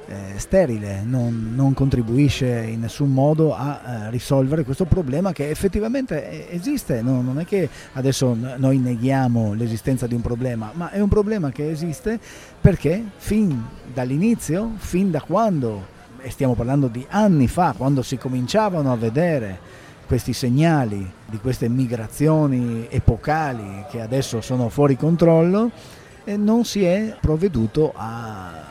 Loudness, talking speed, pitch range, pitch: -21 LUFS, 140 wpm, 120-165 Hz, 135 Hz